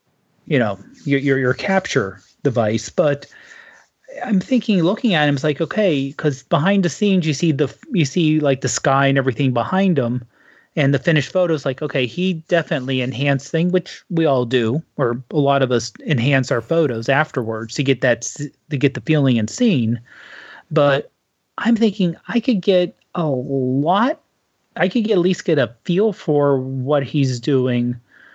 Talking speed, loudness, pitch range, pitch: 180 wpm, -19 LUFS, 130-180 Hz, 150 Hz